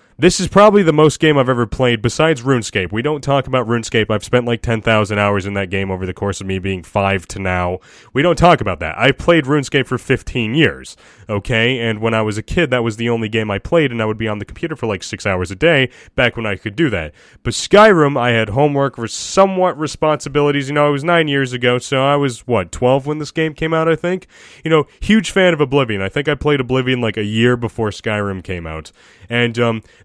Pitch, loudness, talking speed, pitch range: 125 Hz, -16 LUFS, 250 wpm, 110-150 Hz